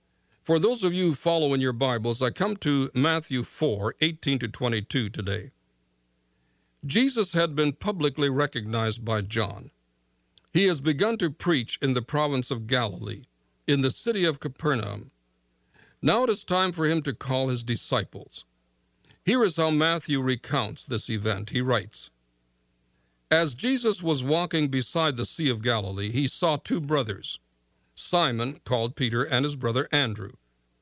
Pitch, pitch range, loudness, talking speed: 130 Hz, 100-155 Hz, -26 LUFS, 150 wpm